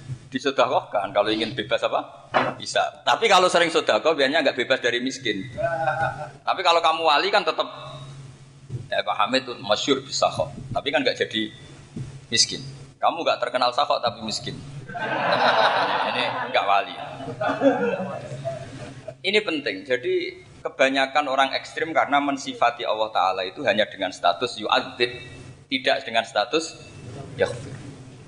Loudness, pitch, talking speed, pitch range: -23 LUFS, 135 Hz, 130 wpm, 125-155 Hz